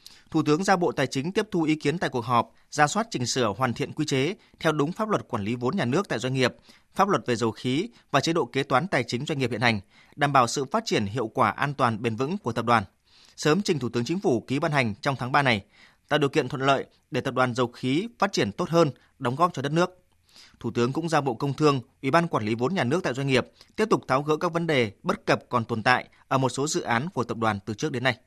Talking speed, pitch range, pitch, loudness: 290 wpm, 120-155 Hz, 135 Hz, -25 LUFS